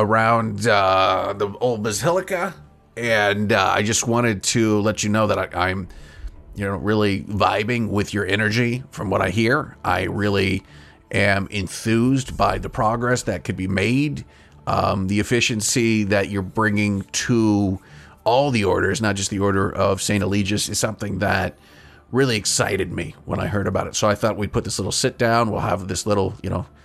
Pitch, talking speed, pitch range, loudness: 105 Hz, 185 wpm, 95-115 Hz, -21 LUFS